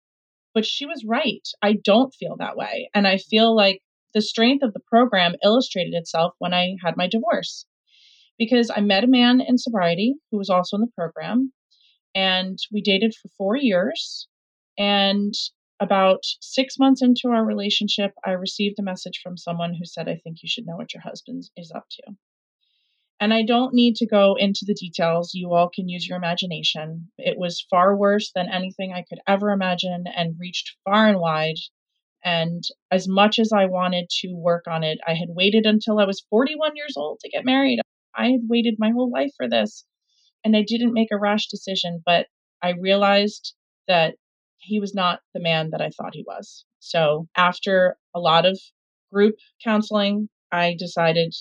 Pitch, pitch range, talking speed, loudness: 200 Hz, 175-225 Hz, 185 wpm, -21 LUFS